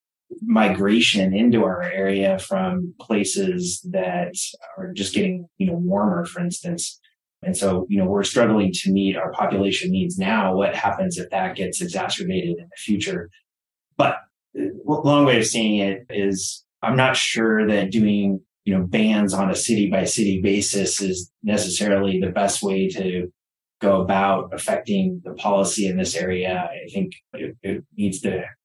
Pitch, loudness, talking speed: 105 Hz, -21 LUFS, 165 wpm